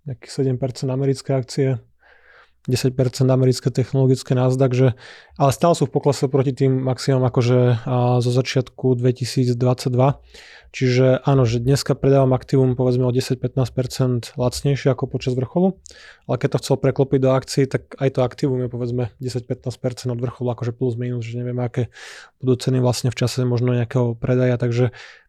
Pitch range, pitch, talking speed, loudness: 125-135 Hz, 130 Hz, 155 wpm, -20 LUFS